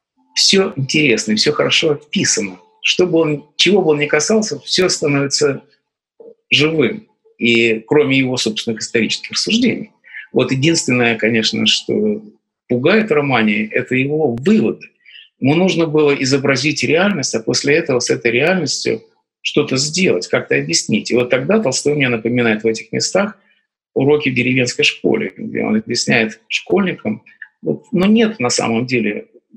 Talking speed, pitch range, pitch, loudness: 135 wpm, 120-165 Hz, 145 Hz, -15 LUFS